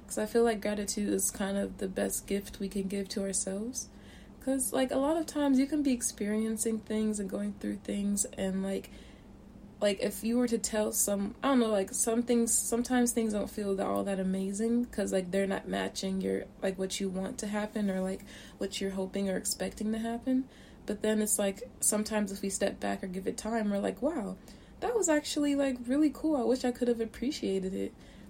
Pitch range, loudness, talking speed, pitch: 195-240 Hz, -31 LUFS, 220 wpm, 215 Hz